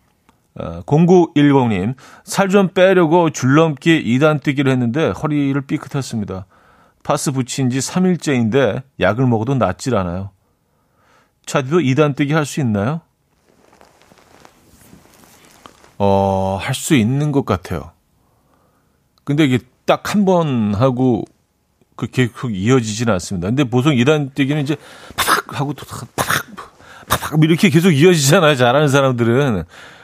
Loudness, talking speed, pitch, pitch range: -16 LUFS, 245 characters per minute, 135 Hz, 115-155 Hz